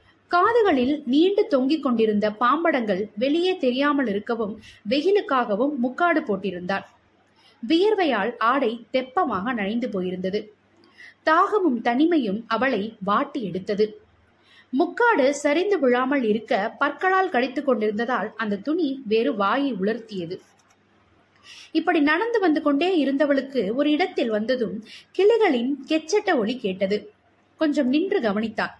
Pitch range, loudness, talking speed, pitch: 220-320 Hz, -22 LUFS, 100 wpm, 265 Hz